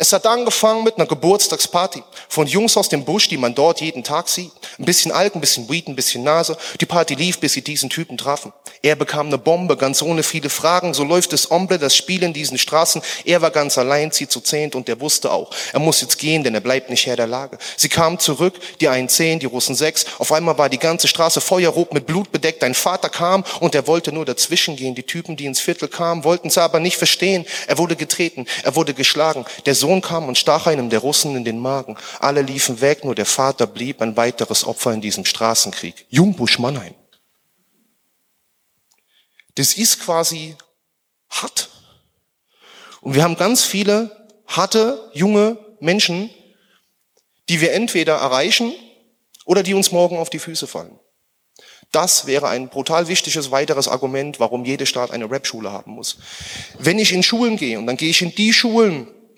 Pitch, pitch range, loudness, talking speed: 160 Hz, 135-180 Hz, -17 LUFS, 195 wpm